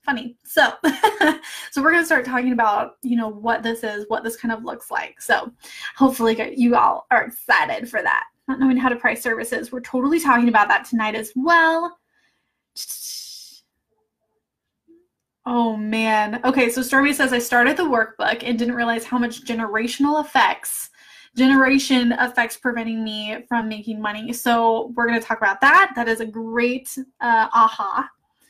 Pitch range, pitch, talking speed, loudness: 225-270 Hz, 240 Hz, 165 wpm, -19 LUFS